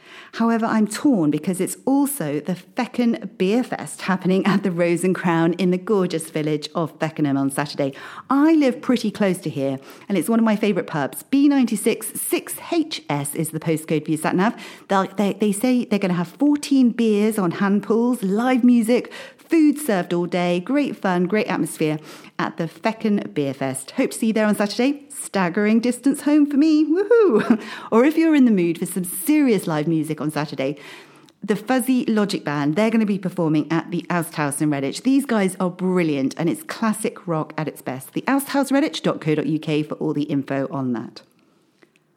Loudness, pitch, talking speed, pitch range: -21 LUFS, 195 Hz, 190 wpm, 160-240 Hz